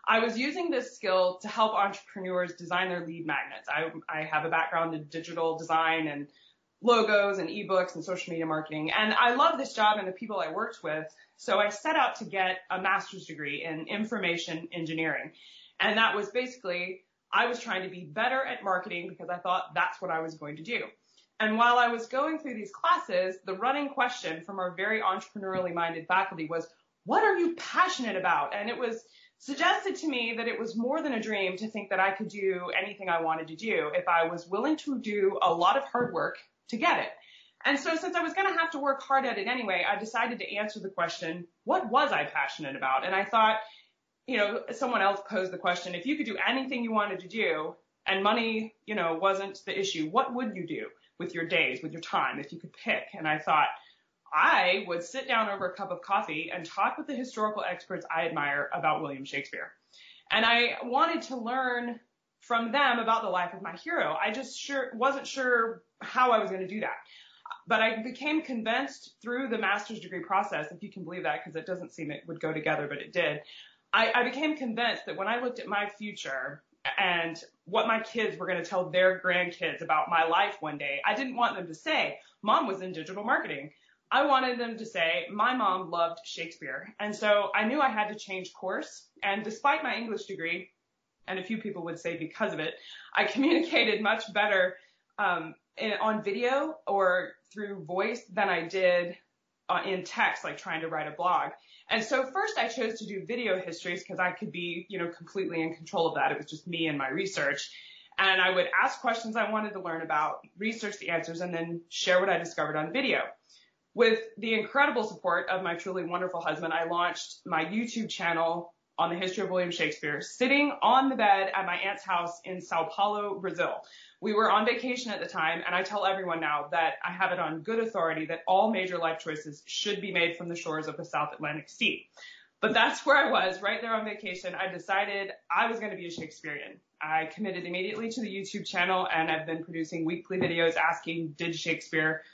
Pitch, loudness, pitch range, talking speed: 195 Hz, -29 LUFS, 170-230 Hz, 215 wpm